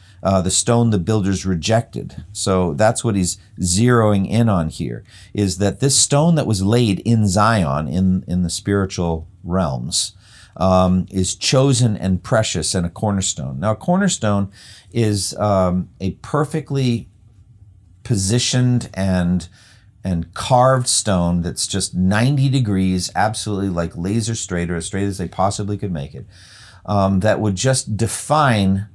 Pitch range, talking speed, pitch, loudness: 95-115 Hz, 145 wpm, 100 Hz, -18 LUFS